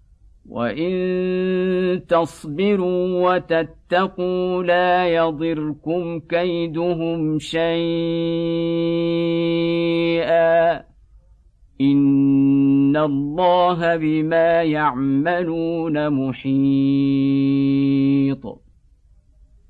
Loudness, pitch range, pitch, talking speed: -19 LUFS, 140-170 Hz, 165 Hz, 35 wpm